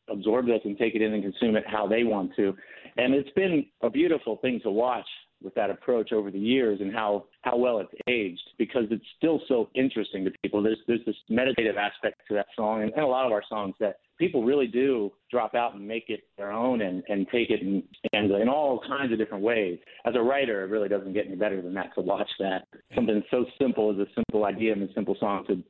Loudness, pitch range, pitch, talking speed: -27 LUFS, 100-120 Hz, 110 Hz, 240 wpm